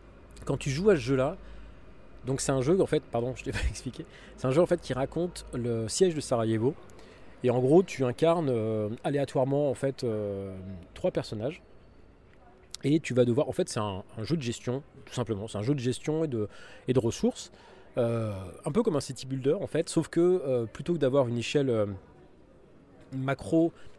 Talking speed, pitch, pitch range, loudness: 210 wpm, 130 Hz, 110-155 Hz, -29 LUFS